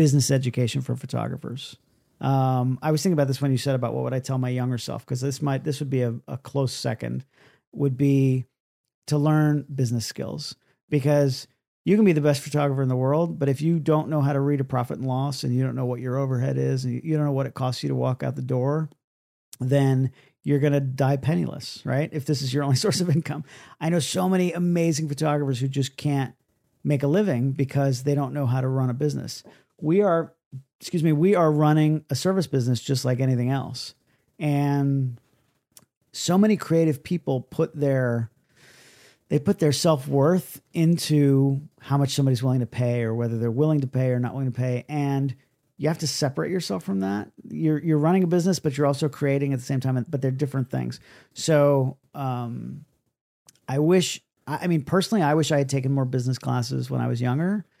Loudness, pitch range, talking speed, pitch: -24 LUFS, 130-150 Hz, 210 wpm, 140 Hz